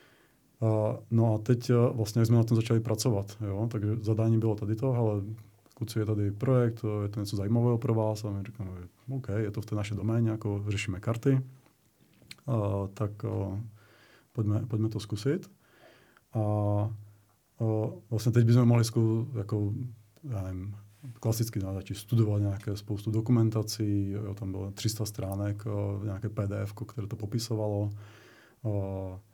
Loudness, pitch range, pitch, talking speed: -30 LUFS, 105-115 Hz, 110 Hz, 165 wpm